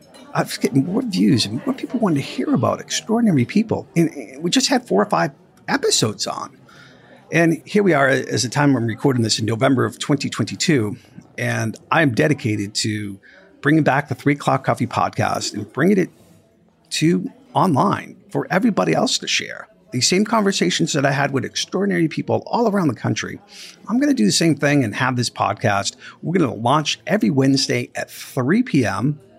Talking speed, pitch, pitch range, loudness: 185 wpm, 145 Hz, 130-190 Hz, -19 LUFS